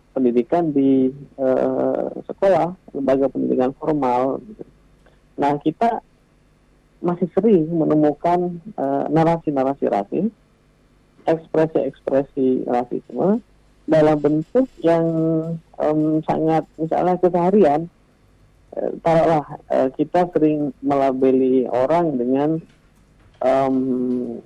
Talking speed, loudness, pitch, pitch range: 80 wpm, -20 LUFS, 150 Hz, 130-165 Hz